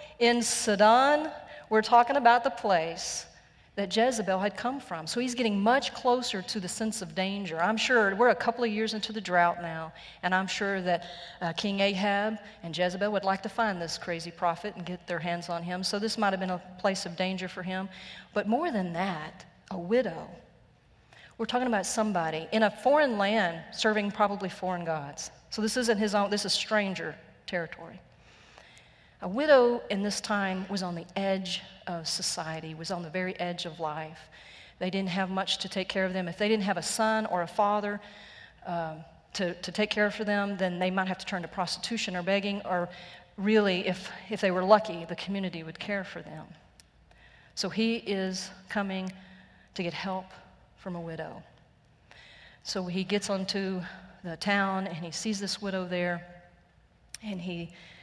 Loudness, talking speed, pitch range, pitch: -29 LUFS, 190 wpm, 175-210 Hz, 190 Hz